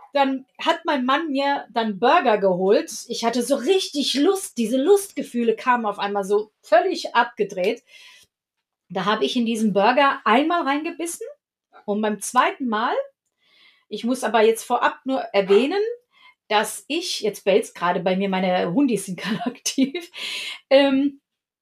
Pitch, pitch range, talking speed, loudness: 245 Hz, 210-285 Hz, 145 wpm, -21 LUFS